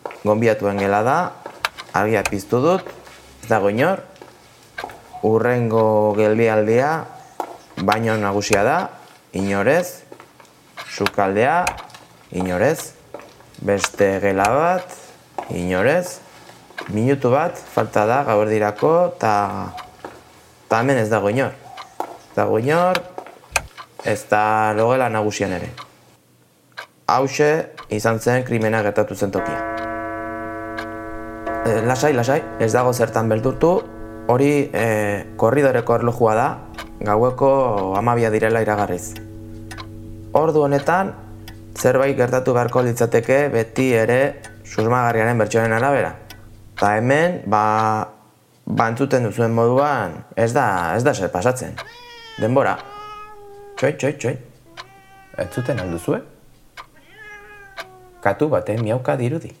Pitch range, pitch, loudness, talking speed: 105-130 Hz, 115 Hz, -19 LUFS, 100 wpm